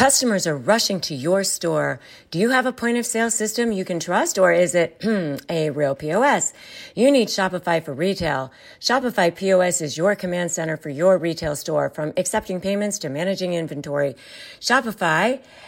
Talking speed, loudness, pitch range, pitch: 170 wpm, -21 LUFS, 160-215 Hz, 185 Hz